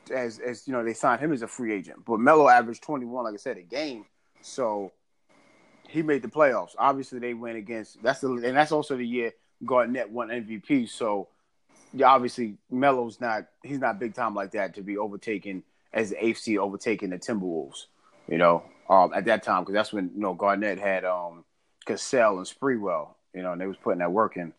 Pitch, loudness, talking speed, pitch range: 110 Hz, -26 LUFS, 210 wpm, 100-125 Hz